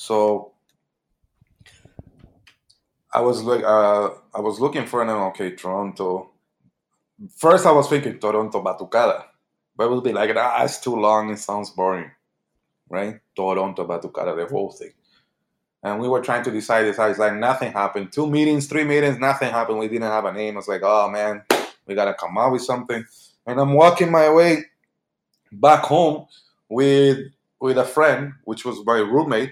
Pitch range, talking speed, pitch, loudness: 105-140 Hz, 170 wpm, 120 Hz, -20 LUFS